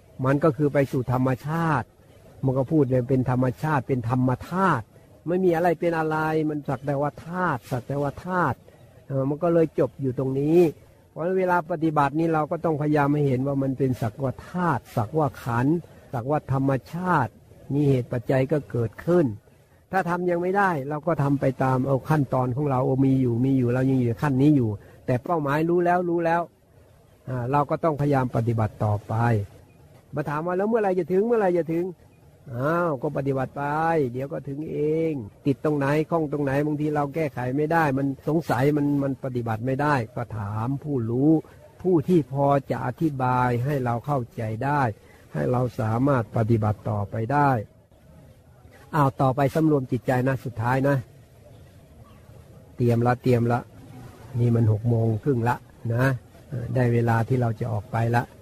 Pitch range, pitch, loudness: 120-150 Hz, 135 Hz, -24 LUFS